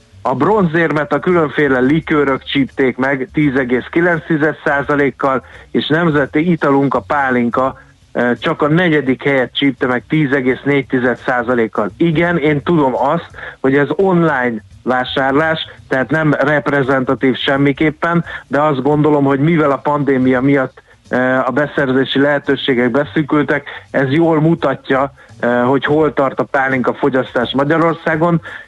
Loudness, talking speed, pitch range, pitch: -14 LUFS, 115 wpm, 130-155 Hz, 140 Hz